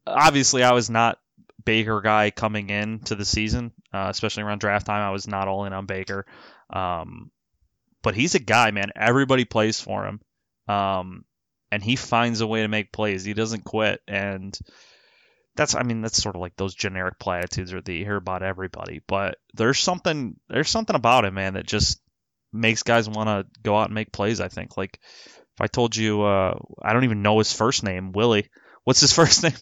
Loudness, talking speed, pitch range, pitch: -22 LUFS, 195 wpm, 100-115 Hz, 105 Hz